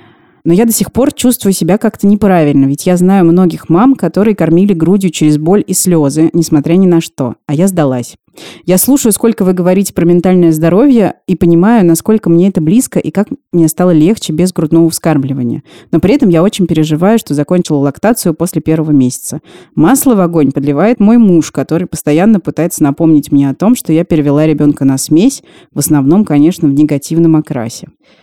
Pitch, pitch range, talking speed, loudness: 170 Hz, 155-195 Hz, 185 wpm, -9 LUFS